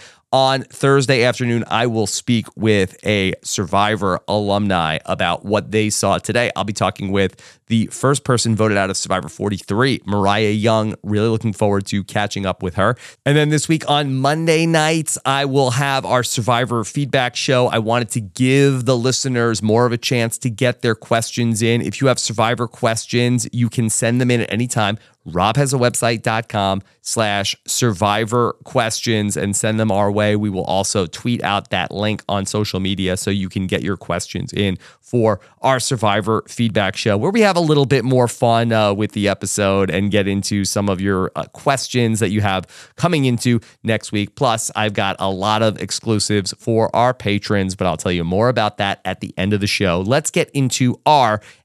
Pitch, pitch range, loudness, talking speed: 110 Hz, 100-125 Hz, -18 LUFS, 195 wpm